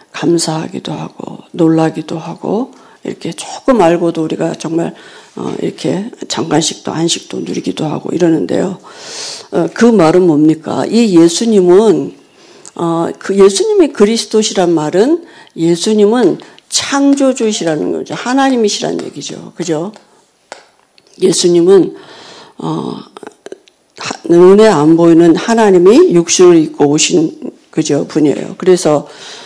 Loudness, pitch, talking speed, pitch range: -11 LUFS, 195 Hz, 260 characters per minute, 165-265 Hz